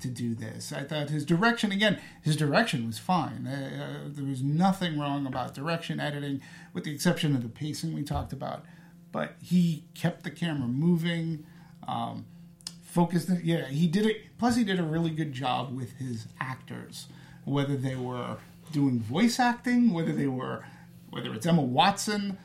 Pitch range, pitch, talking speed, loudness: 140-175 Hz, 160 Hz, 170 wpm, -29 LUFS